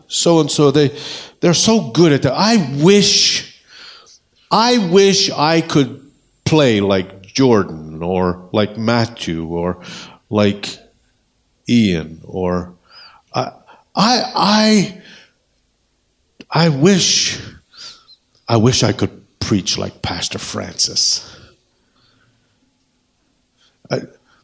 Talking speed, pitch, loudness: 95 wpm, 145 Hz, -15 LUFS